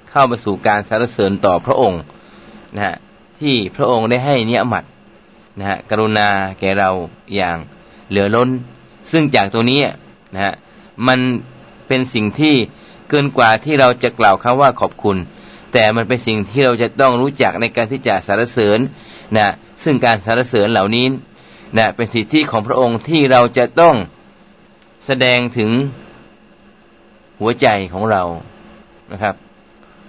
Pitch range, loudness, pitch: 105-130 Hz, -15 LUFS, 115 Hz